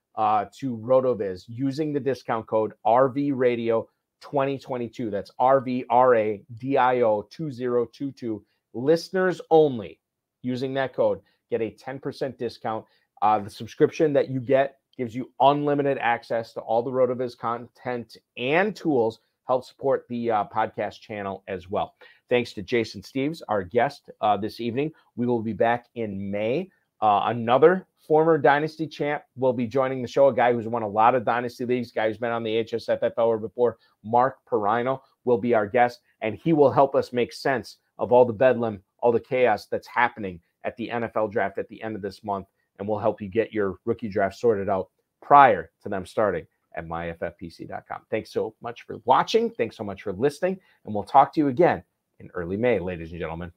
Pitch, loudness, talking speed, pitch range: 120 Hz, -24 LUFS, 175 wpm, 110-135 Hz